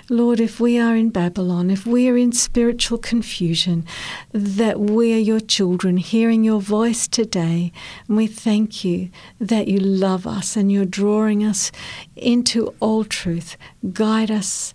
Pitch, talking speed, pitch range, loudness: 215 Hz, 155 wpm, 190-230 Hz, -19 LUFS